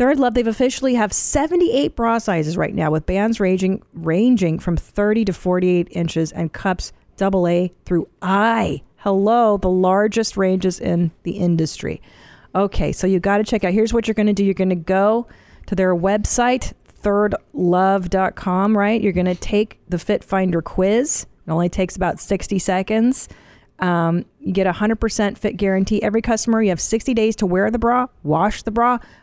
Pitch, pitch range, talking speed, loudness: 195 Hz, 180-220 Hz, 180 wpm, -19 LUFS